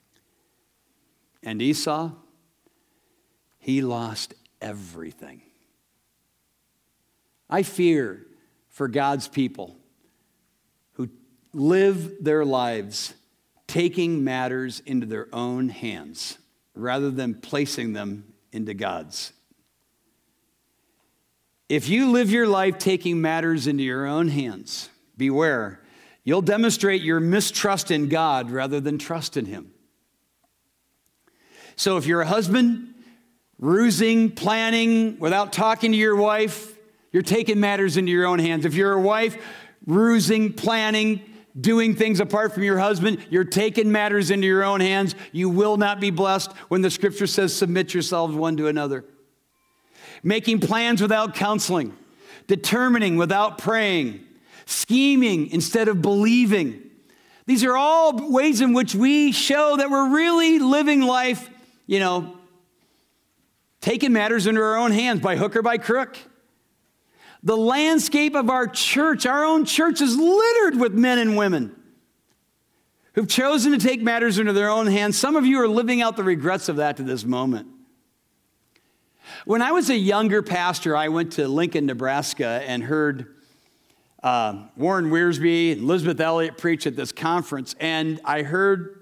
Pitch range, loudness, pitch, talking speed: 155-230 Hz, -21 LUFS, 195 Hz, 135 wpm